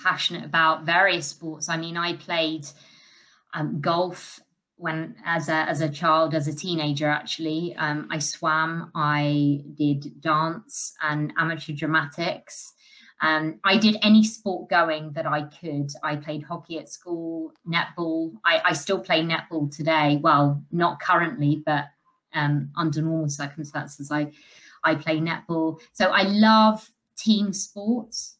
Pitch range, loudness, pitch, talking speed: 150-175 Hz, -24 LUFS, 160 Hz, 140 wpm